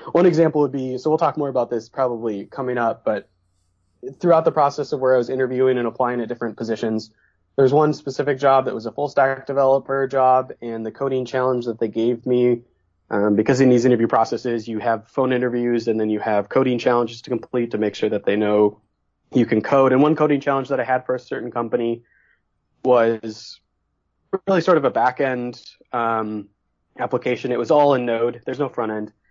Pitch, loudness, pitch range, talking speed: 120 Hz, -20 LUFS, 110-135 Hz, 210 wpm